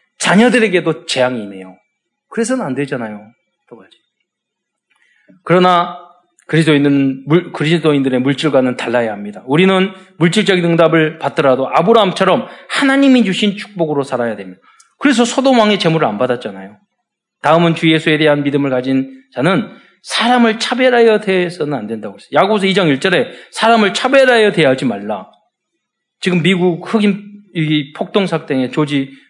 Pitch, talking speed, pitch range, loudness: 170 Hz, 350 characters per minute, 140-205 Hz, -13 LUFS